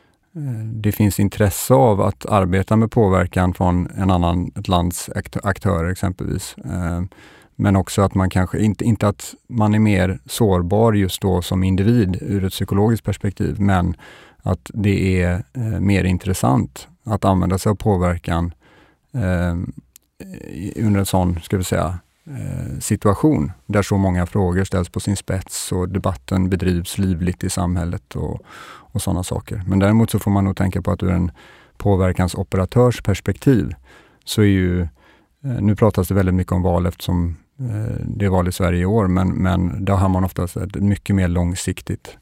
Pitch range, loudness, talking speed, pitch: 90-105 Hz, -19 LUFS, 160 wpm, 95 Hz